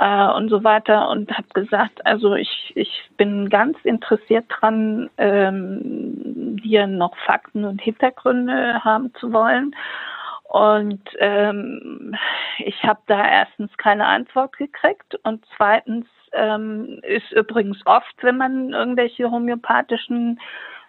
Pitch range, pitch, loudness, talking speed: 210-250 Hz, 220 Hz, -19 LUFS, 120 wpm